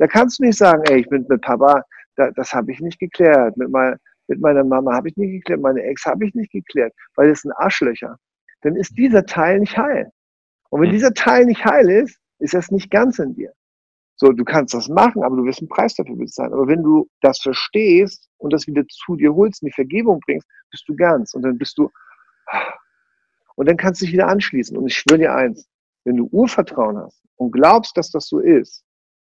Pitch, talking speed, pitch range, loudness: 170 Hz, 220 wpm, 135-215 Hz, -16 LUFS